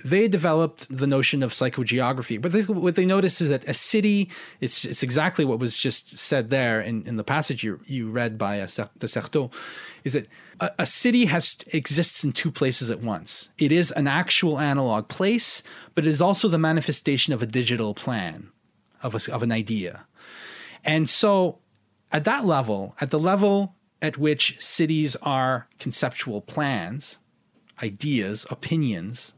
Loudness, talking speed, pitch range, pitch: -23 LUFS, 170 wpm, 120-170 Hz, 145 Hz